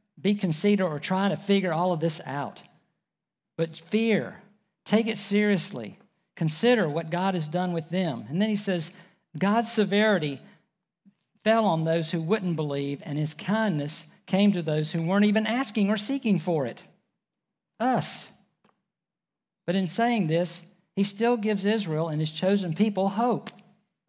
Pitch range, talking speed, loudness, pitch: 170-210 Hz, 155 wpm, -26 LUFS, 190 Hz